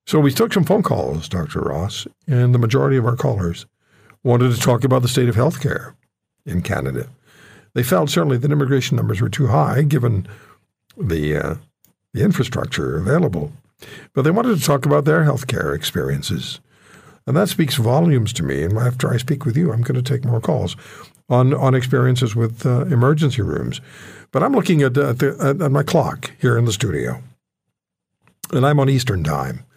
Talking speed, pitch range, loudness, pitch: 185 wpm, 115-145 Hz, -18 LUFS, 130 Hz